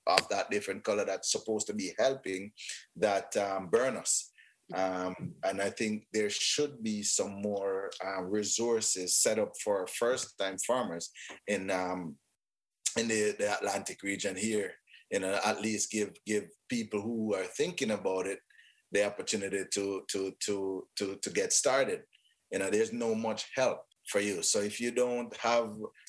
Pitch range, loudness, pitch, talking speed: 100-115 Hz, -32 LUFS, 105 Hz, 165 wpm